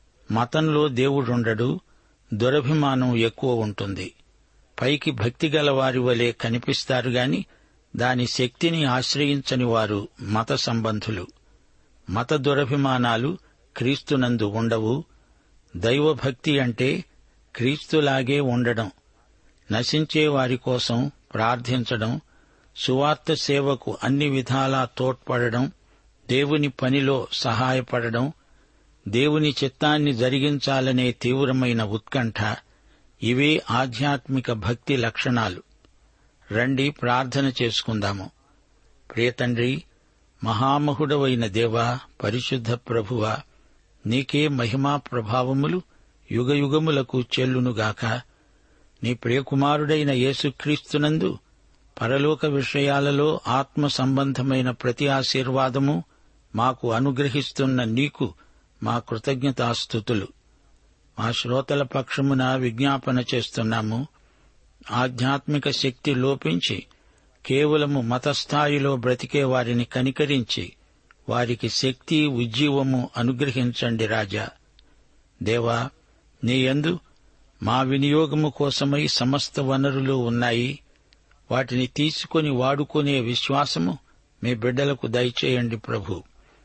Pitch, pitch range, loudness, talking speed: 130 Hz, 120-140 Hz, -23 LUFS, 75 wpm